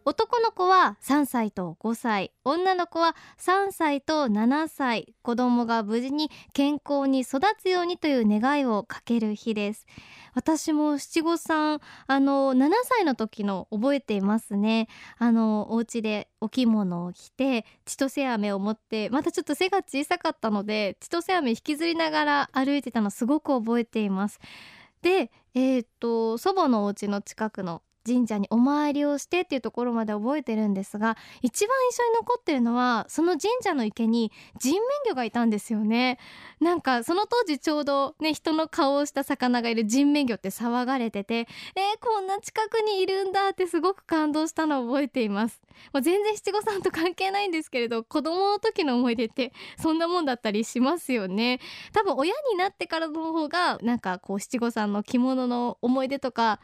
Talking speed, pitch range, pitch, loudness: 335 characters per minute, 225-330 Hz, 270 Hz, -26 LUFS